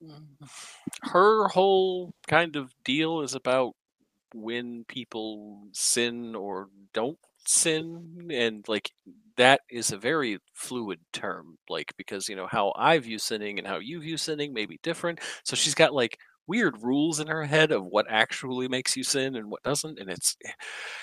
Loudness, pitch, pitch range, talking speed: -27 LUFS, 135 Hz, 115-160 Hz, 165 wpm